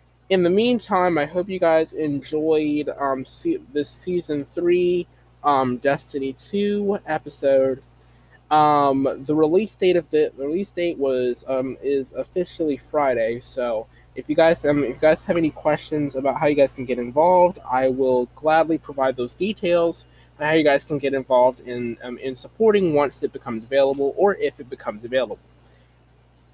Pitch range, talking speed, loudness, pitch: 130-170 Hz, 170 wpm, -21 LUFS, 145 Hz